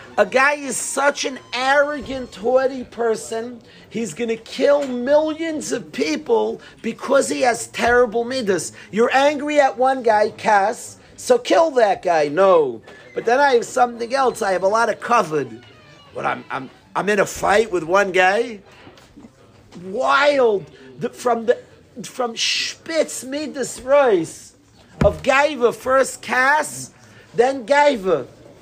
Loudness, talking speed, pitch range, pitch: -19 LUFS, 140 wpm, 225-285 Hz, 250 Hz